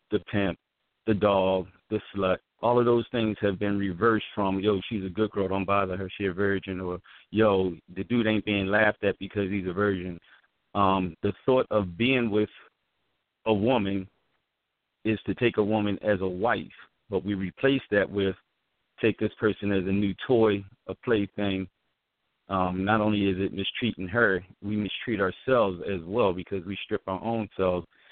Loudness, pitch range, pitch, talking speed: -27 LUFS, 95-105 Hz, 100 Hz, 180 wpm